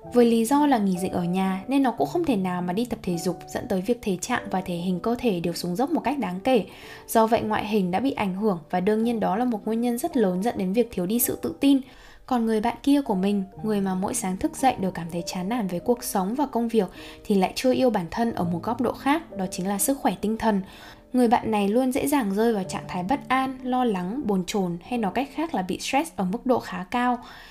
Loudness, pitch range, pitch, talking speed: -25 LUFS, 190-250 Hz, 225 Hz, 285 wpm